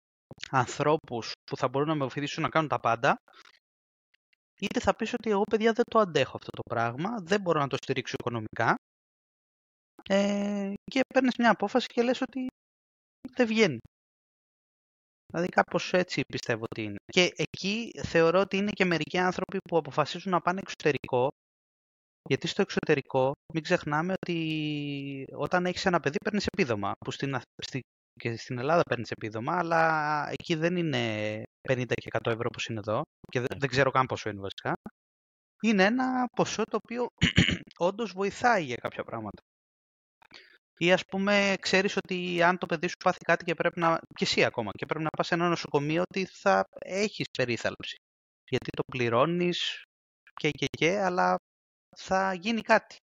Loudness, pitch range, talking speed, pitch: -28 LUFS, 130-195 Hz, 165 wpm, 165 Hz